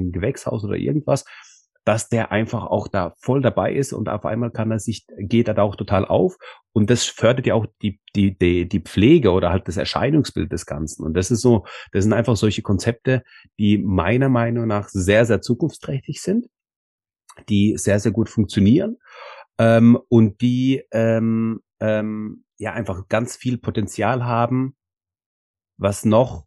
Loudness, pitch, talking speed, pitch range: -20 LUFS, 110 Hz, 170 wpm, 100-120 Hz